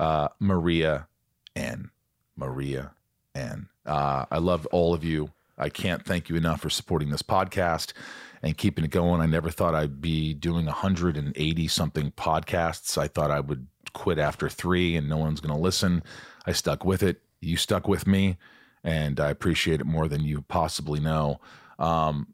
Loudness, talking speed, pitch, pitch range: -27 LUFS, 170 wpm, 80 Hz, 75-85 Hz